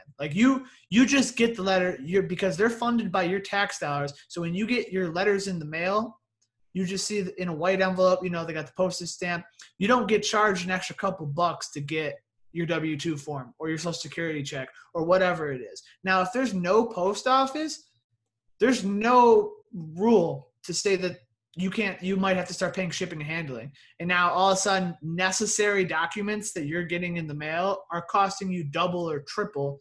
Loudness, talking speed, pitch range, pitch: -26 LUFS, 210 wpm, 165-200 Hz, 185 Hz